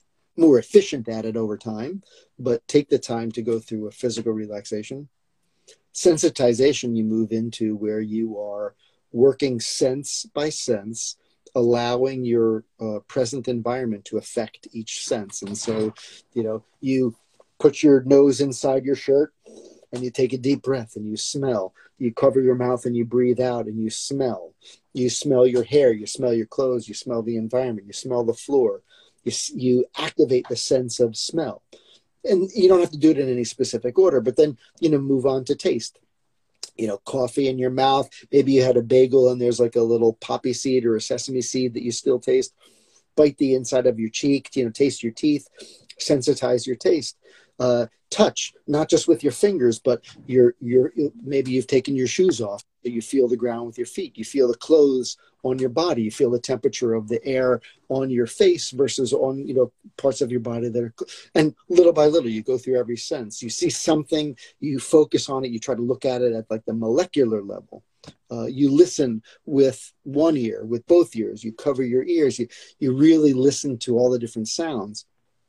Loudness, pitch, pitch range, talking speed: -22 LUFS, 125 Hz, 115-140 Hz, 200 wpm